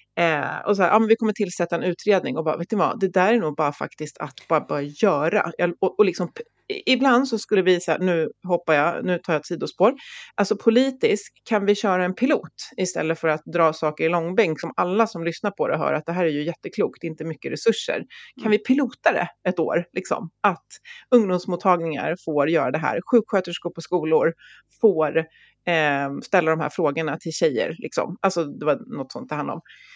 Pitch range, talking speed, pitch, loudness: 160-215 Hz, 210 wpm, 175 Hz, -22 LUFS